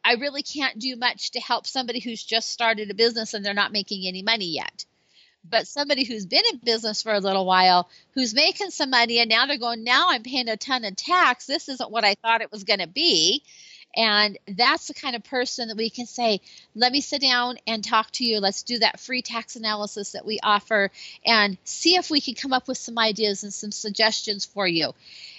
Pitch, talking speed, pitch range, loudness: 230 Hz, 230 wpm, 210-260 Hz, -22 LUFS